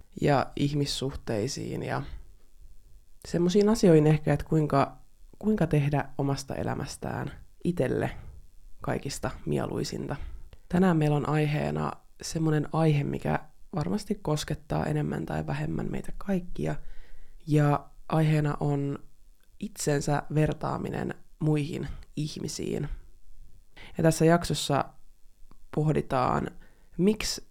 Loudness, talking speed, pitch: -28 LUFS, 90 wpm, 145 Hz